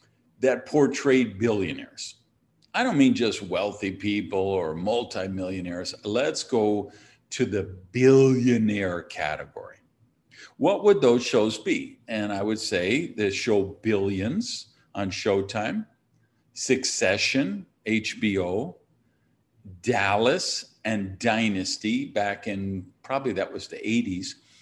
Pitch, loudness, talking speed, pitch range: 110 Hz, -25 LUFS, 105 wpm, 100-130 Hz